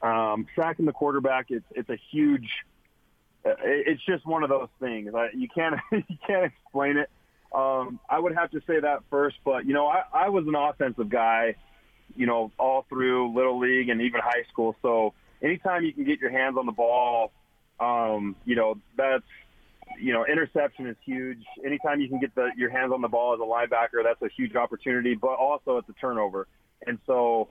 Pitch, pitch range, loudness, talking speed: 130 Hz, 120-150 Hz, -26 LUFS, 200 wpm